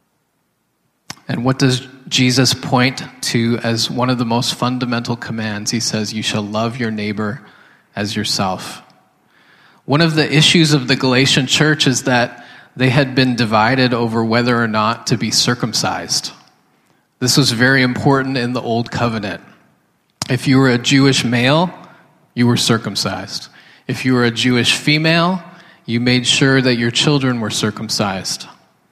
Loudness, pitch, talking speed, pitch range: -15 LUFS, 125 Hz, 155 wpm, 115-135 Hz